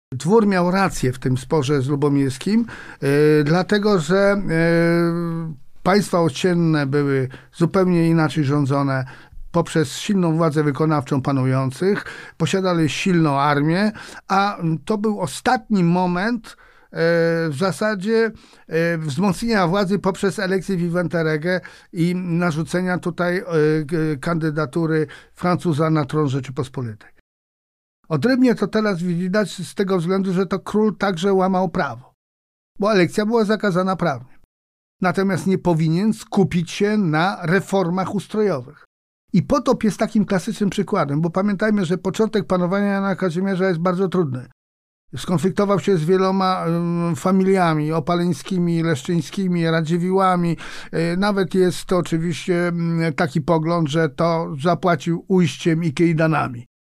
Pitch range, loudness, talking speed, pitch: 160-195 Hz, -20 LUFS, 110 wpm, 175 Hz